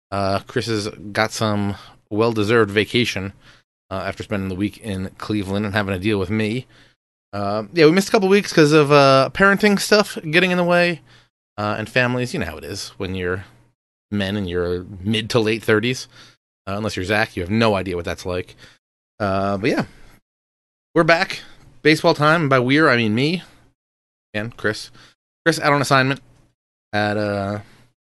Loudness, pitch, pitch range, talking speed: -19 LUFS, 110 Hz, 100-135 Hz, 180 wpm